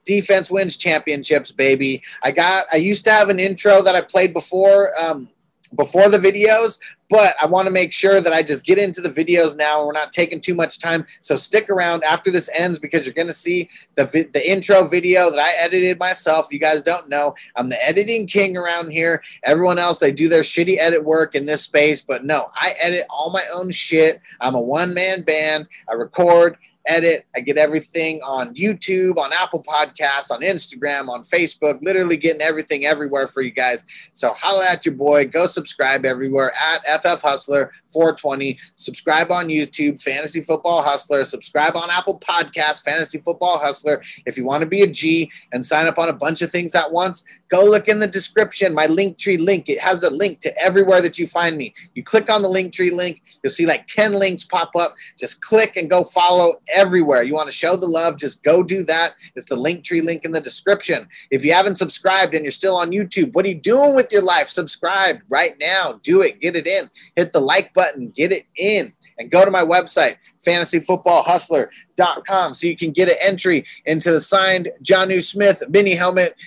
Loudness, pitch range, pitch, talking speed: -16 LUFS, 155-185 Hz, 170 Hz, 205 wpm